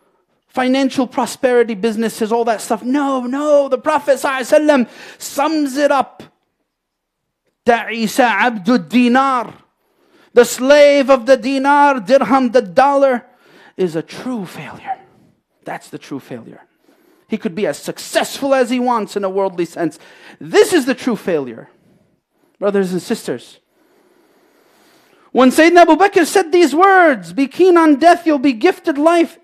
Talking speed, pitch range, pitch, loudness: 135 wpm, 235-320 Hz, 270 Hz, -14 LUFS